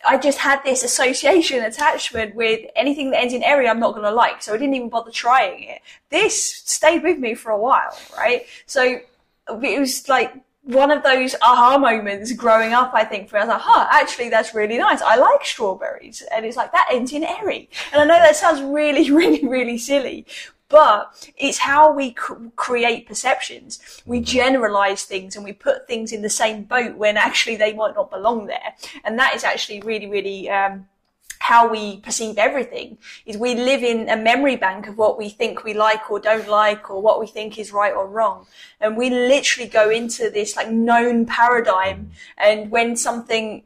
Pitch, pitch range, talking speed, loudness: 240 Hz, 220-275 Hz, 200 wpm, -18 LUFS